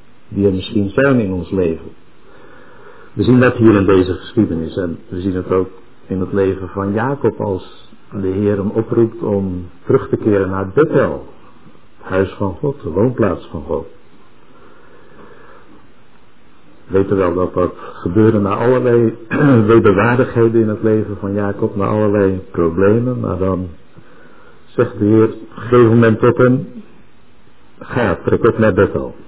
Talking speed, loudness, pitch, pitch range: 150 wpm, -15 LUFS, 105 Hz, 95-115 Hz